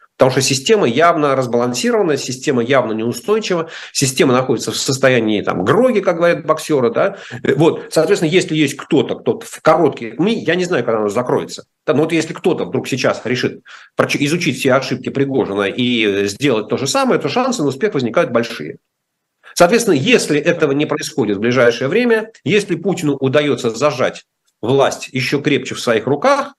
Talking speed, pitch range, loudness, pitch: 165 wpm, 130-175 Hz, -16 LUFS, 150 Hz